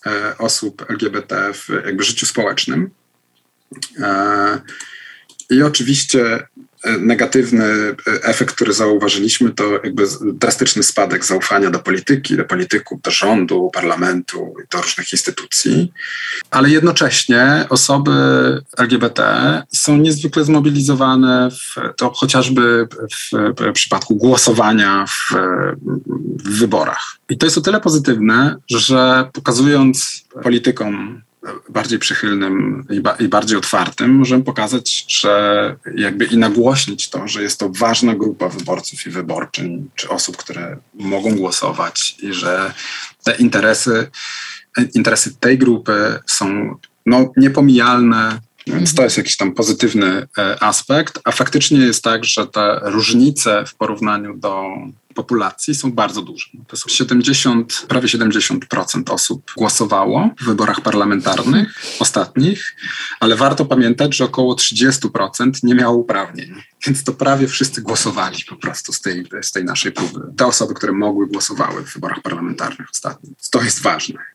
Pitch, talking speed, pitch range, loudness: 125 Hz, 125 wpm, 110-135 Hz, -15 LUFS